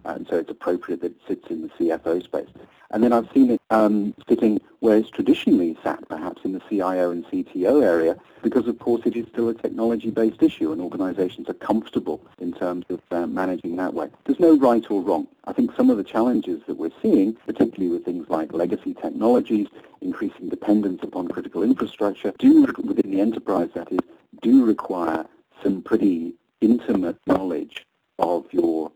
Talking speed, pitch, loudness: 180 wpm, 275 Hz, -22 LUFS